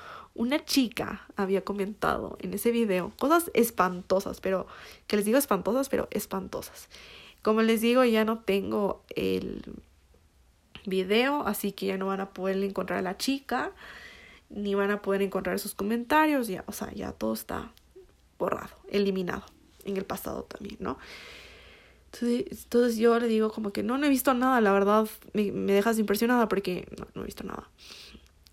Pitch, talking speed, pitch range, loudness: 205 Hz, 165 wpm, 195-235 Hz, -28 LUFS